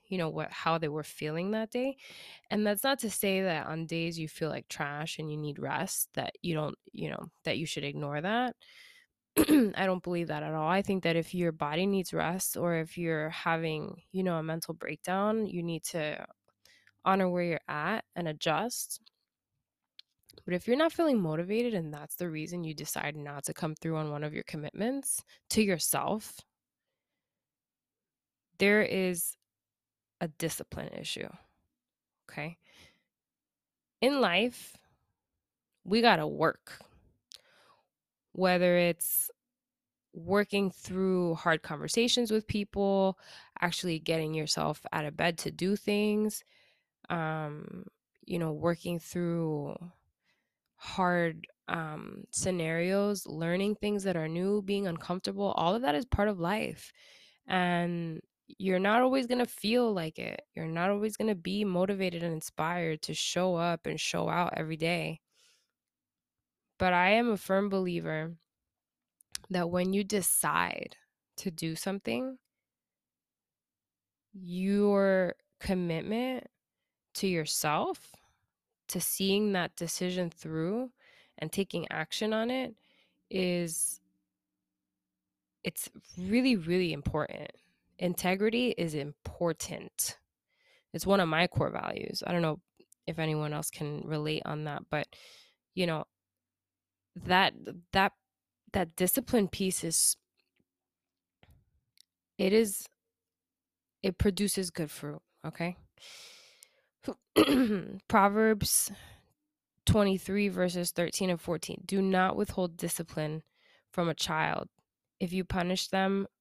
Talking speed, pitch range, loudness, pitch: 130 wpm, 160-205 Hz, -31 LUFS, 180 Hz